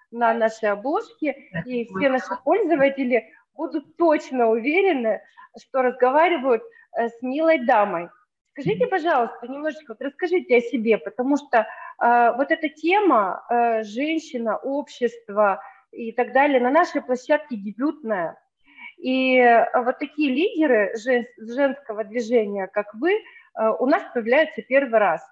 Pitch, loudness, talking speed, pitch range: 260 Hz, -22 LUFS, 125 wpm, 235-320 Hz